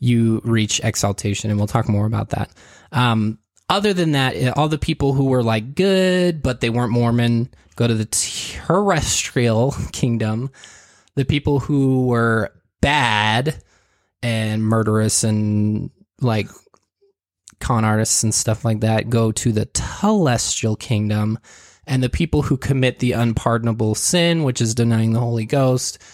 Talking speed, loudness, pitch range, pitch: 145 wpm, -19 LUFS, 110-130 Hz, 115 Hz